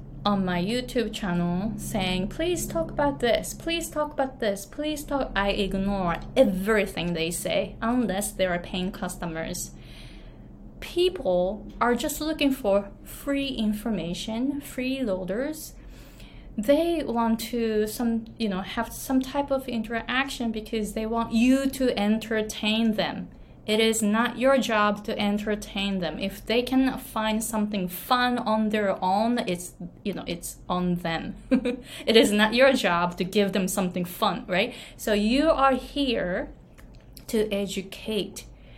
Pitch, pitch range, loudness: 220 Hz, 195-255 Hz, -26 LUFS